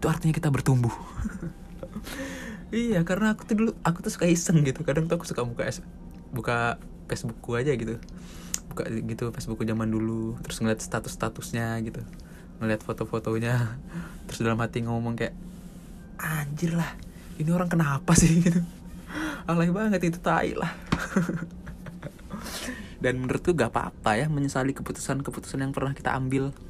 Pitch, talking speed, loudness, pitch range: 145 Hz, 140 wpm, -28 LUFS, 115-175 Hz